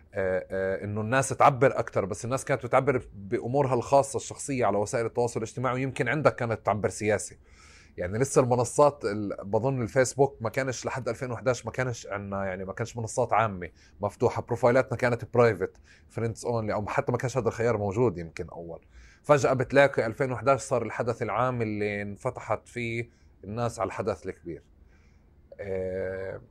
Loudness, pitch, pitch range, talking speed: -27 LUFS, 115 Hz, 100-130 Hz, 155 wpm